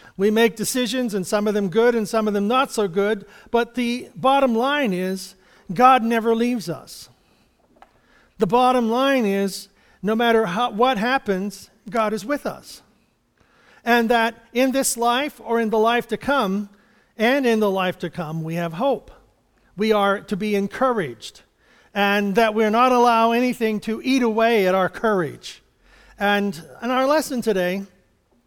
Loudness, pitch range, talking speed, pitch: -20 LUFS, 200-245 Hz, 165 wpm, 225 Hz